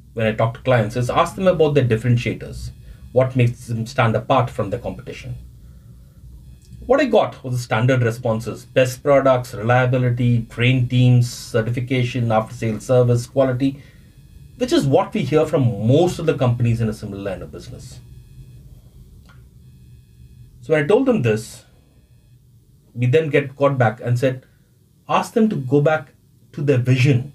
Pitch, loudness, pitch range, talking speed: 125 Hz, -19 LUFS, 115-135 Hz, 160 wpm